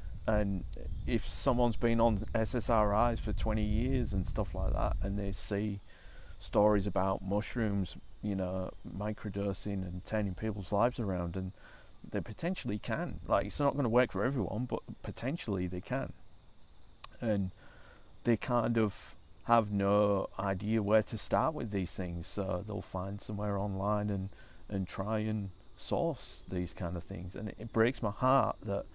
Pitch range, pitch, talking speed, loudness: 95-110 Hz, 105 Hz, 160 wpm, -34 LUFS